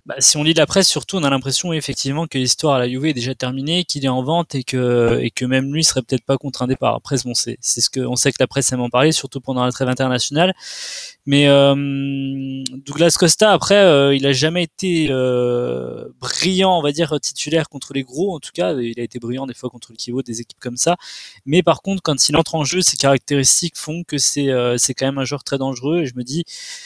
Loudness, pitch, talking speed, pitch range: -17 LUFS, 140 Hz, 255 wpm, 130-160 Hz